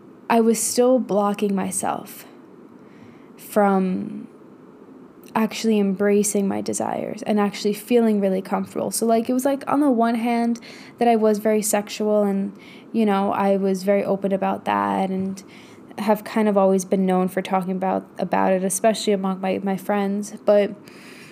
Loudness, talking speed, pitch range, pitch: -21 LUFS, 160 wpm, 195-220 Hz, 205 Hz